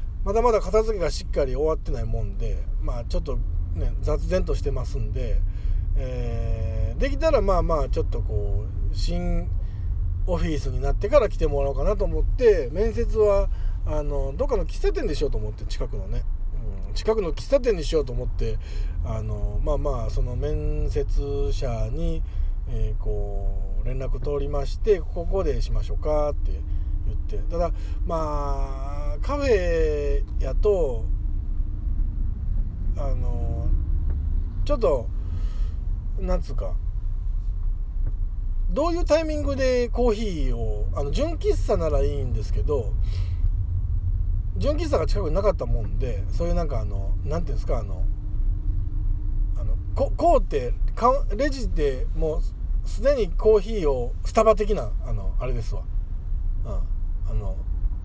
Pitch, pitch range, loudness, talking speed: 95 Hz, 85-115 Hz, -26 LUFS, 285 characters per minute